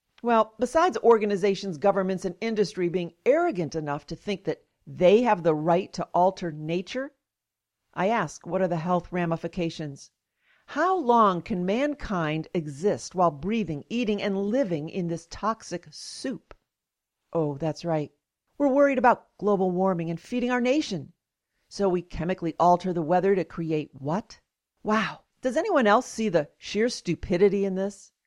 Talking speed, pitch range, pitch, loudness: 150 wpm, 170-220 Hz, 190 Hz, -26 LUFS